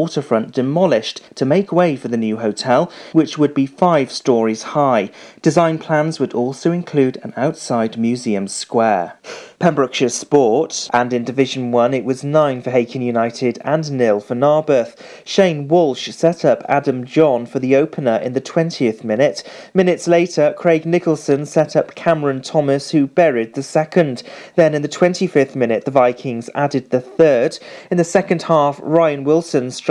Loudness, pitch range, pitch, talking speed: -17 LUFS, 125-160 Hz, 140 Hz, 165 wpm